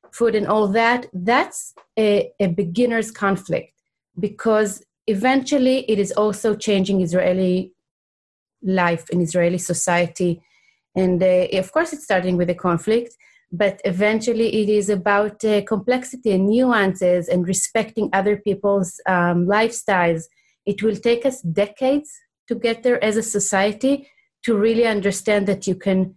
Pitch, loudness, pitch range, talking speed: 205 Hz, -20 LUFS, 185-225 Hz, 140 wpm